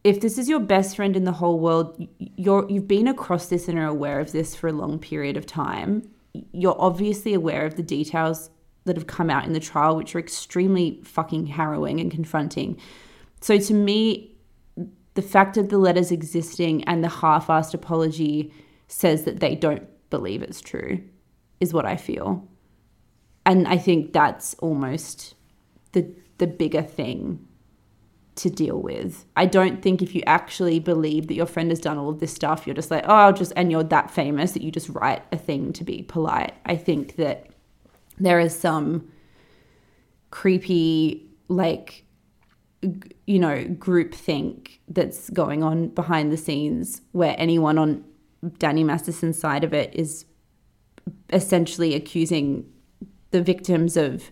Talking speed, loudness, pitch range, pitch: 165 wpm, -23 LUFS, 155-180 Hz, 165 Hz